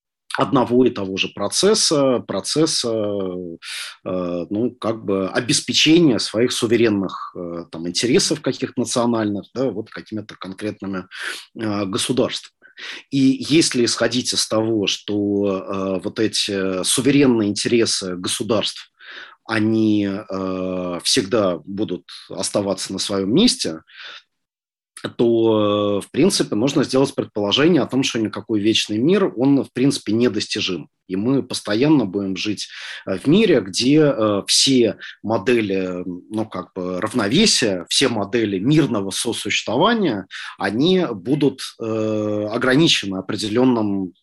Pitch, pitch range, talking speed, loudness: 110 Hz, 95-125 Hz, 105 wpm, -19 LUFS